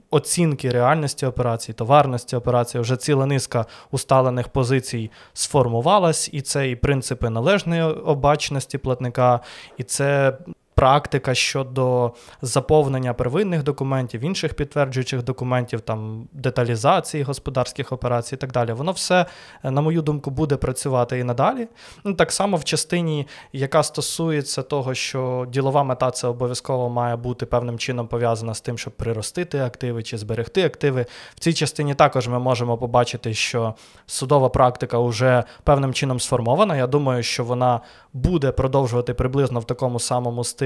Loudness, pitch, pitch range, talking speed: -21 LUFS, 130 Hz, 120-145 Hz, 140 wpm